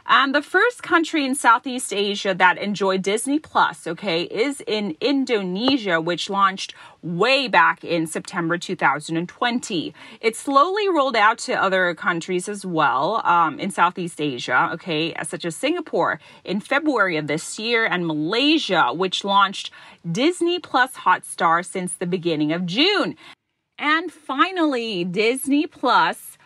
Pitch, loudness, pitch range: 205 Hz, -20 LUFS, 175-275 Hz